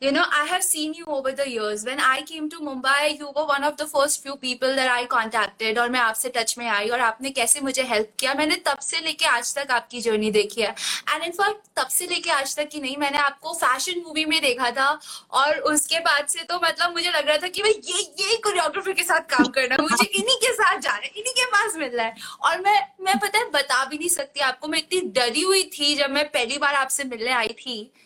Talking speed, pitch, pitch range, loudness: 215 wpm, 290 Hz, 255-330 Hz, -22 LUFS